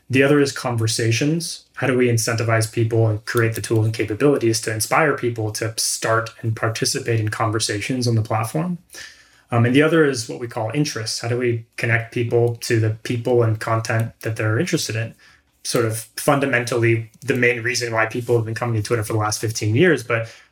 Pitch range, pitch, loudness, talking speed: 115-125 Hz, 115 Hz, -20 LUFS, 200 wpm